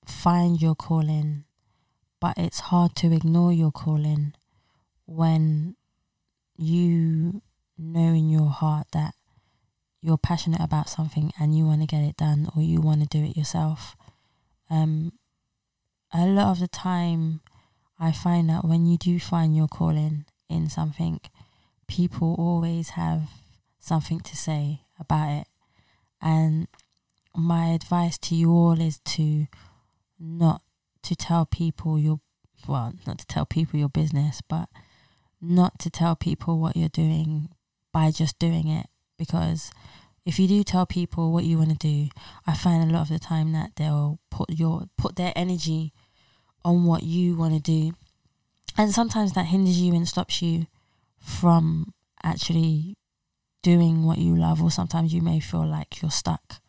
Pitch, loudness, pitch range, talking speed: 160 Hz, -24 LUFS, 150-170 Hz, 155 wpm